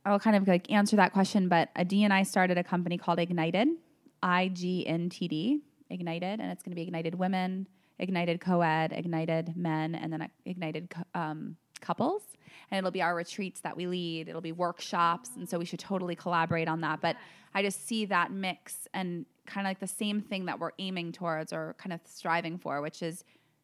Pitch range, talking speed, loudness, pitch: 165-195 Hz, 210 wpm, -31 LUFS, 175 Hz